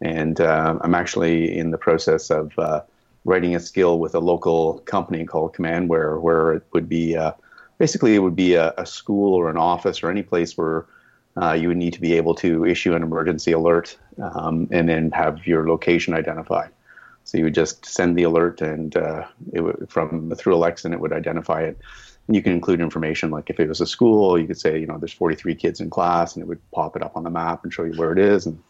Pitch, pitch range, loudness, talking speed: 85 Hz, 80-85 Hz, -21 LUFS, 235 wpm